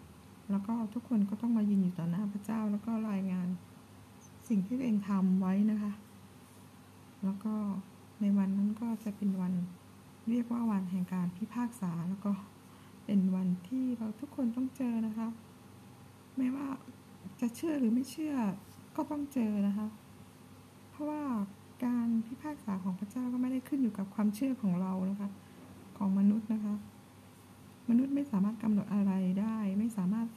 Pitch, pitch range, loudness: 215 Hz, 195-240 Hz, -34 LUFS